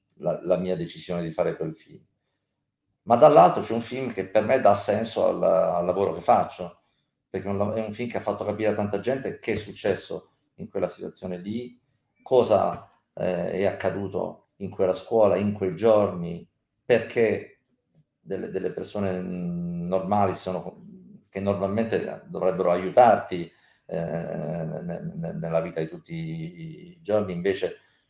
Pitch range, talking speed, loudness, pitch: 90-125 Hz, 145 wpm, -25 LUFS, 105 Hz